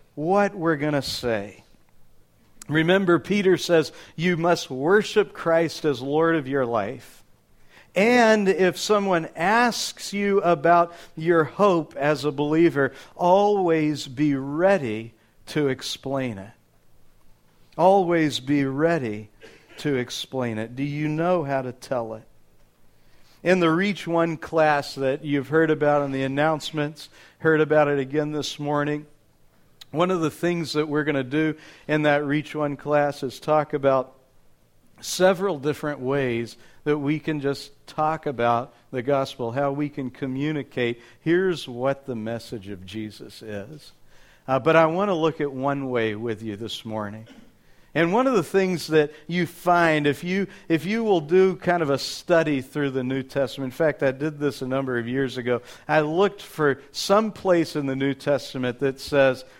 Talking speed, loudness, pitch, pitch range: 160 wpm, -23 LUFS, 150 Hz, 135-165 Hz